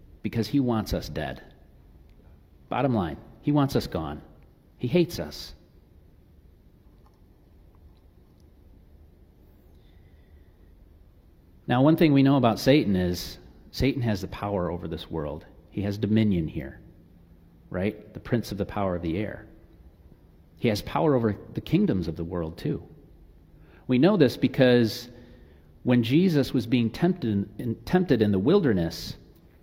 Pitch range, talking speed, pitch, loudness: 80-115 Hz, 135 wpm, 90 Hz, -25 LUFS